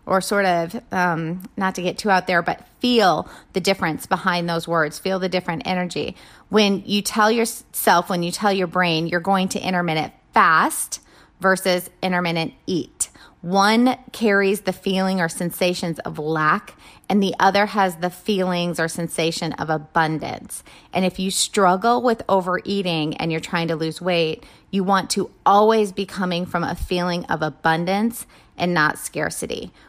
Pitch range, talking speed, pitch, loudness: 170-200 Hz, 165 wpm, 185 Hz, -21 LUFS